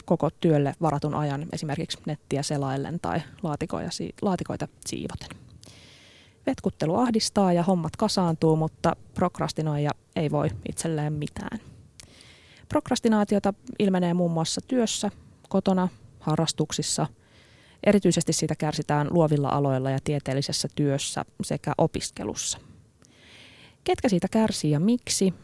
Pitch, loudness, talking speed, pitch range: 160 Hz, -26 LUFS, 105 wpm, 145-190 Hz